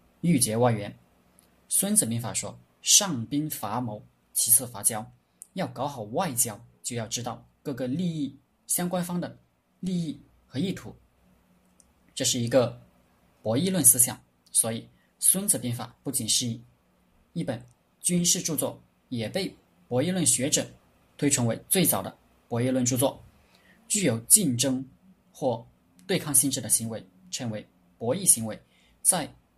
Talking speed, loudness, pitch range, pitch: 205 characters per minute, -25 LUFS, 90-145 Hz, 120 Hz